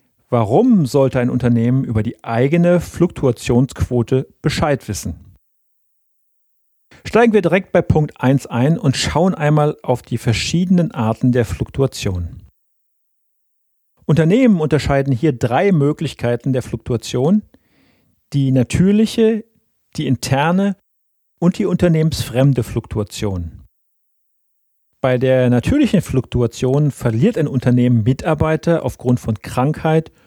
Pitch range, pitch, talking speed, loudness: 120-160 Hz, 130 Hz, 105 wpm, -16 LUFS